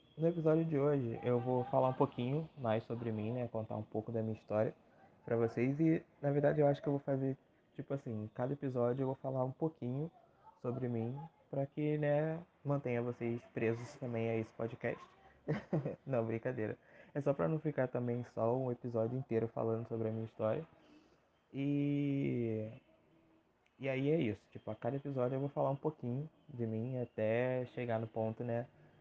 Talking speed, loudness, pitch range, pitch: 185 wpm, -38 LUFS, 115-140 Hz, 125 Hz